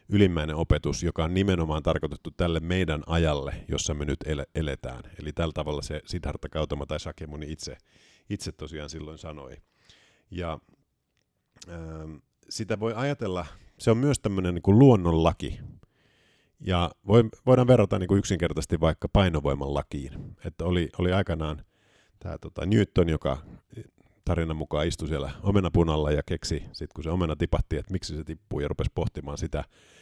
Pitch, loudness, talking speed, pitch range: 85 Hz, -27 LUFS, 150 wpm, 75-95 Hz